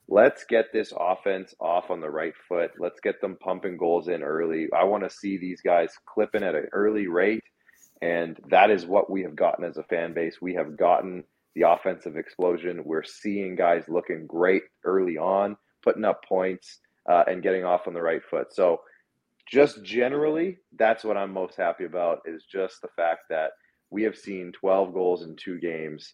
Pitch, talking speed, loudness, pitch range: 95 Hz, 195 wpm, -26 LUFS, 85-105 Hz